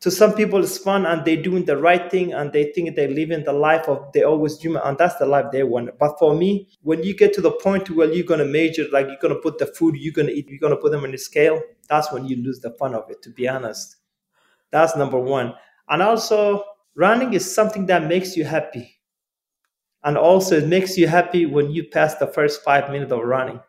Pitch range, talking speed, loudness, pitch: 140-185 Hz, 245 wpm, -19 LUFS, 160 Hz